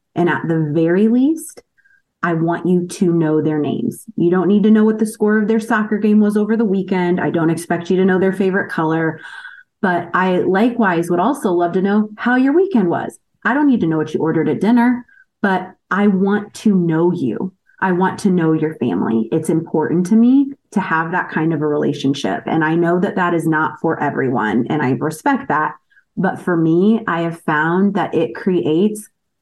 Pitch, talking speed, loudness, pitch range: 185 Hz, 210 wpm, -16 LUFS, 165-215 Hz